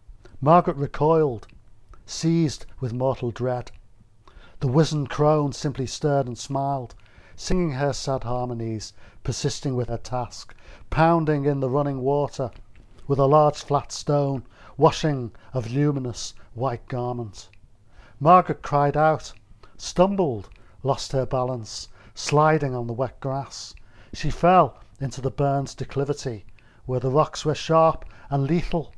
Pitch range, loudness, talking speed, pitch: 115-145 Hz, -24 LUFS, 125 wpm, 130 Hz